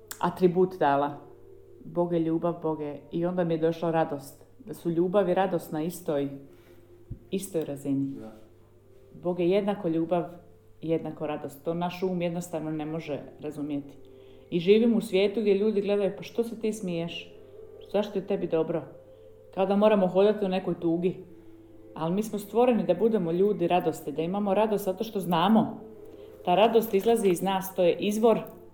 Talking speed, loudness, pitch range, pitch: 165 wpm, -27 LUFS, 150-205 Hz, 175 Hz